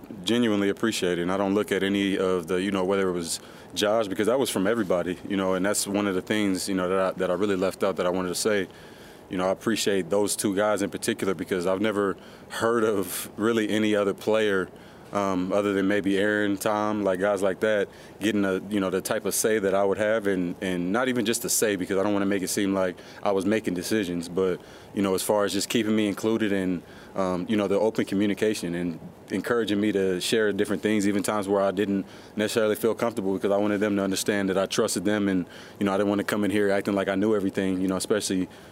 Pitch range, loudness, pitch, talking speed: 95-105 Hz, -25 LUFS, 100 Hz, 255 wpm